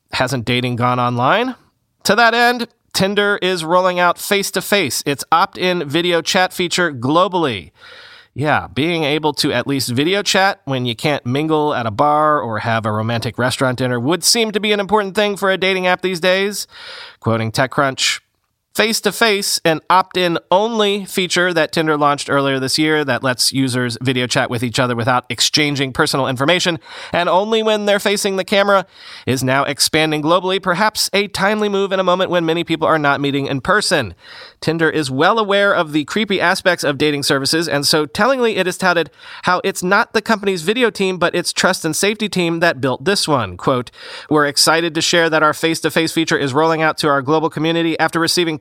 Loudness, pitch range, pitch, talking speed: -16 LUFS, 140-195 Hz, 165 Hz, 200 wpm